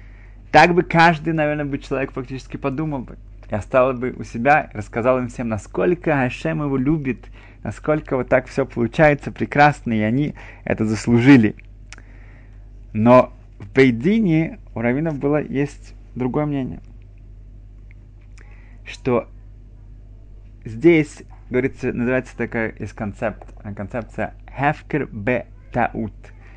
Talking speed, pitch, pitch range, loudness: 115 wpm, 115 Hz, 105-135 Hz, -19 LUFS